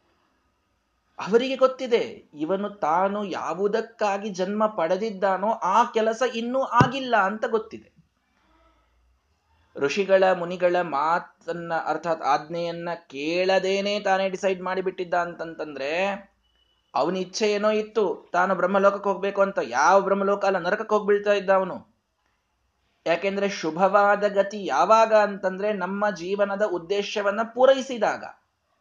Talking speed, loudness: 100 wpm, -24 LUFS